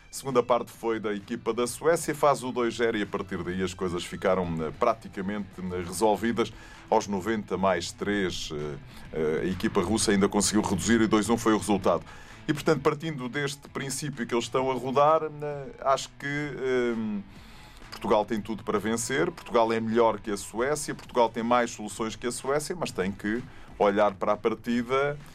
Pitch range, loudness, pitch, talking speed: 105-130 Hz, -27 LUFS, 115 Hz, 175 wpm